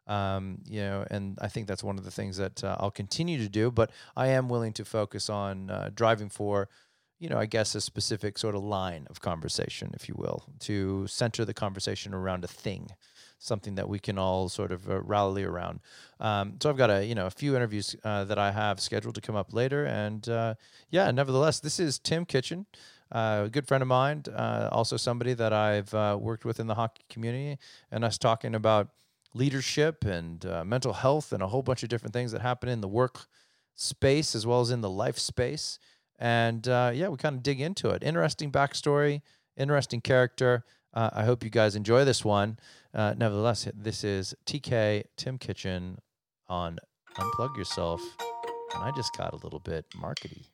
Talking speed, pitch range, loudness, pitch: 200 wpm, 100-130 Hz, -30 LUFS, 115 Hz